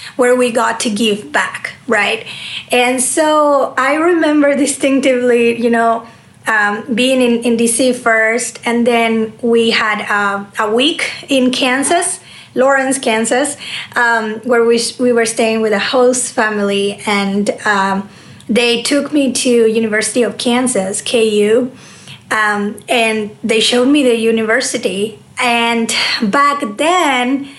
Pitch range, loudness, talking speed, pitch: 225-260 Hz, -13 LUFS, 135 wpm, 235 Hz